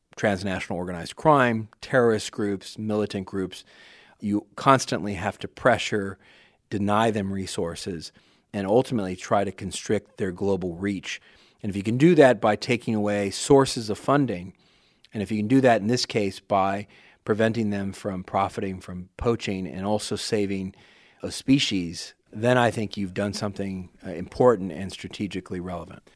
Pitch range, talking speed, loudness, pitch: 95-110 Hz, 150 wpm, -25 LUFS, 100 Hz